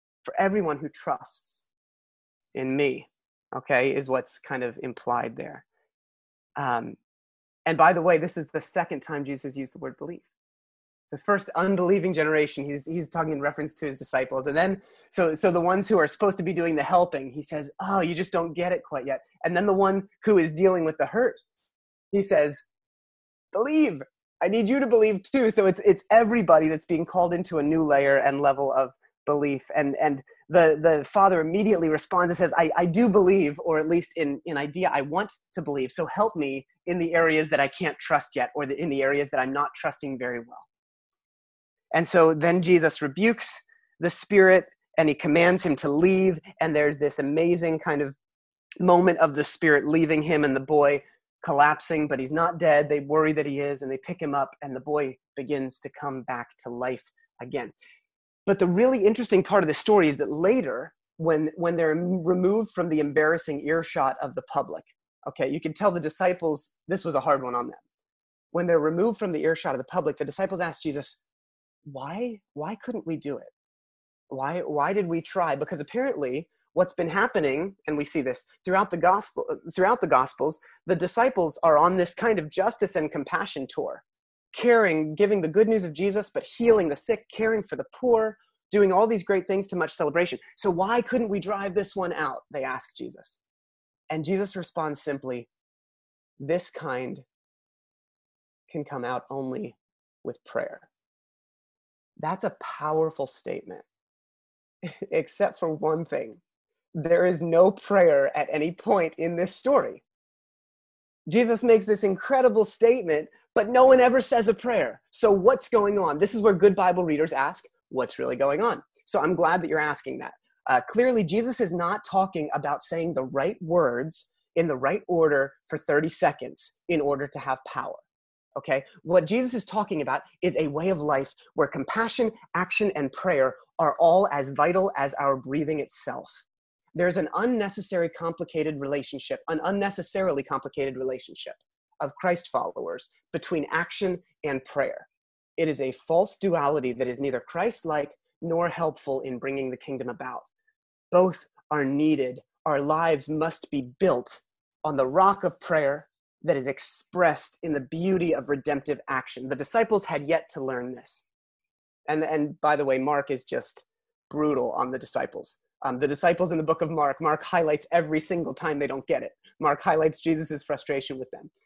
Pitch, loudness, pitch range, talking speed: 165 Hz, -25 LUFS, 145-195 Hz, 185 wpm